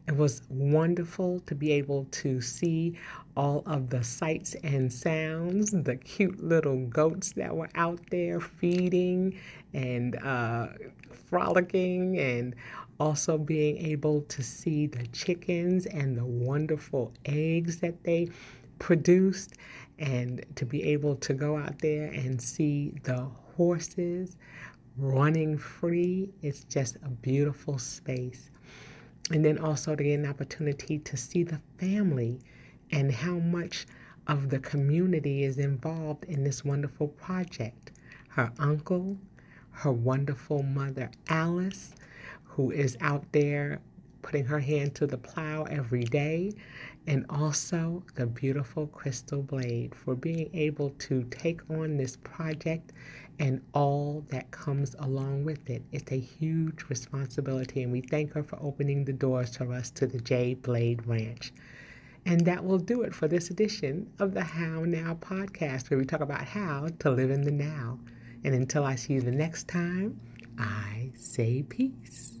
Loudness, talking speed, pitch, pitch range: -30 LUFS, 145 wpm, 145 Hz, 130-165 Hz